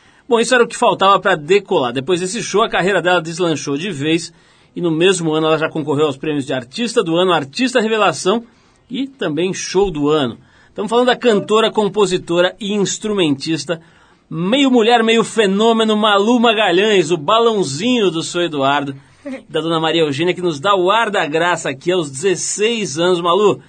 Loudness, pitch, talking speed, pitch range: -15 LUFS, 185 Hz, 180 wpm, 160-220 Hz